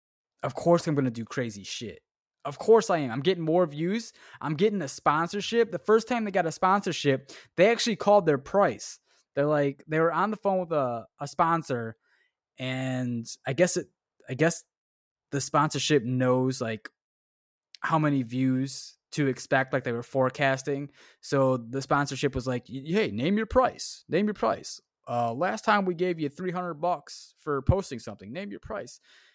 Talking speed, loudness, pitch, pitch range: 180 wpm, -27 LUFS, 145 Hz, 130-180 Hz